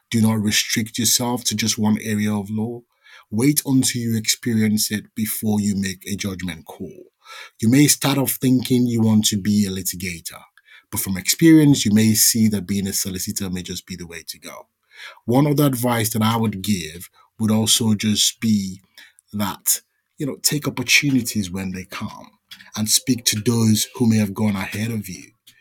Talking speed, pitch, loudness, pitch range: 185 wpm, 110 Hz, -19 LUFS, 100-120 Hz